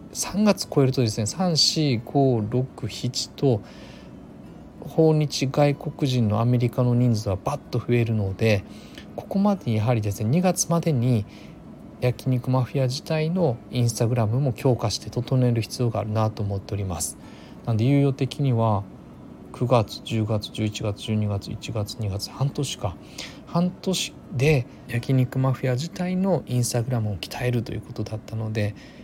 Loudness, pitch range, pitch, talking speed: -24 LUFS, 110-140 Hz, 125 Hz, 305 characters per minute